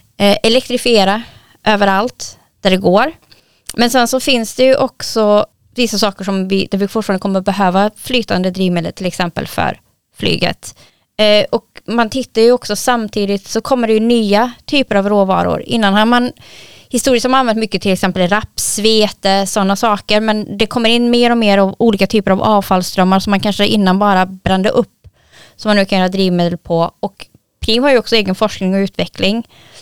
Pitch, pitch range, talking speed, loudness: 210 Hz, 195-235 Hz, 185 wpm, -14 LUFS